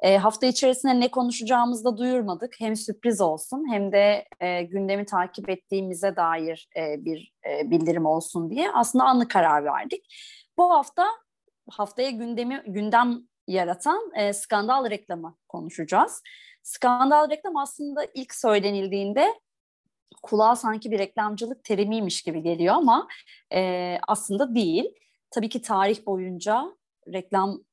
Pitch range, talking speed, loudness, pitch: 190-260 Hz, 125 wpm, -24 LUFS, 220 Hz